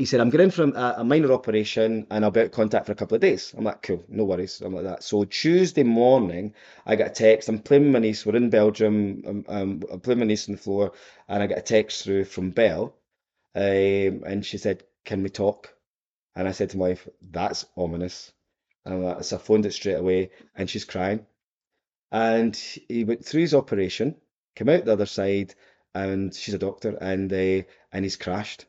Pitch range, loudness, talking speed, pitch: 95-115 Hz, -24 LUFS, 225 wpm, 105 Hz